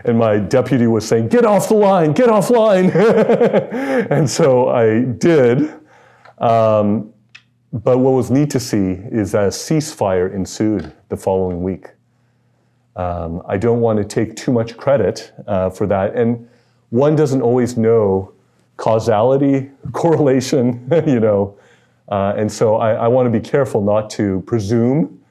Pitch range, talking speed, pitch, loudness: 105-140 Hz, 150 wpm, 120 Hz, -16 LUFS